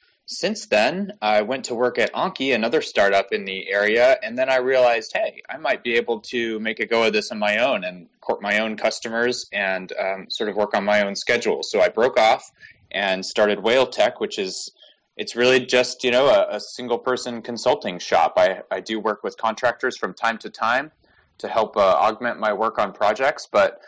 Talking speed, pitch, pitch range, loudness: 210 wpm, 115 Hz, 105-125 Hz, -21 LUFS